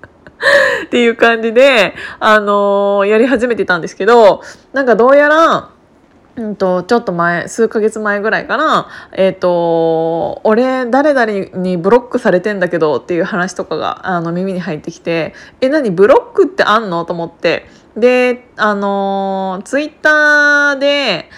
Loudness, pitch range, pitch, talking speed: -12 LUFS, 185-250 Hz, 210 Hz, 290 characters per minute